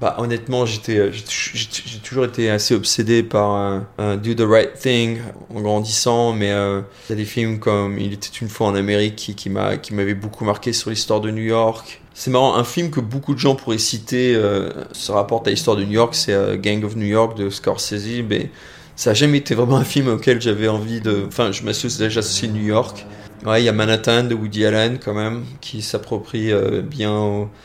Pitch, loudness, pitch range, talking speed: 110 Hz, -19 LUFS, 105-120 Hz, 225 wpm